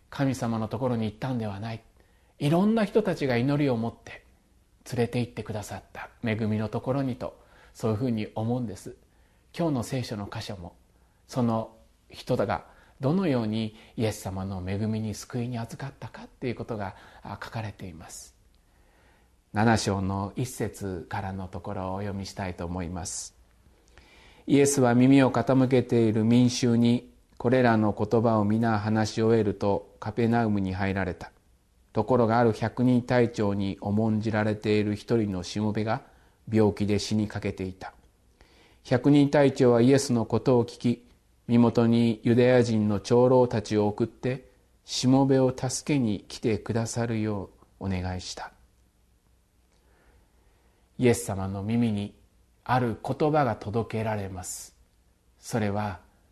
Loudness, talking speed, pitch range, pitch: -26 LUFS, 295 characters per minute, 100-125 Hz, 110 Hz